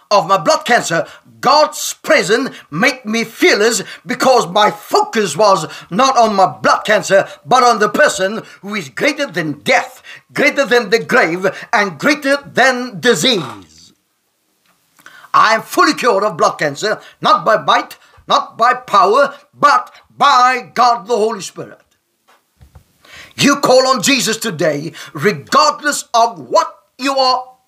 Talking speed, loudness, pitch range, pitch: 140 wpm, -13 LUFS, 210-280 Hz, 240 Hz